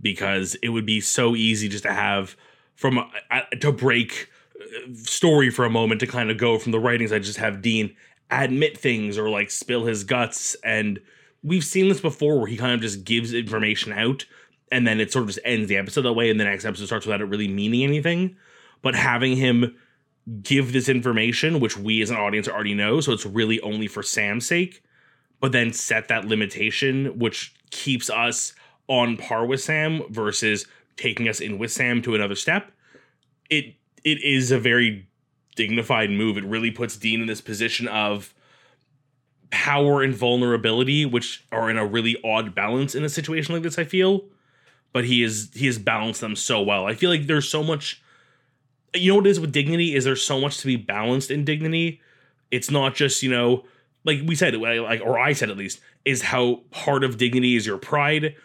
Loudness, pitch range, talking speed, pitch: -22 LUFS, 110-140 Hz, 200 wpm, 120 Hz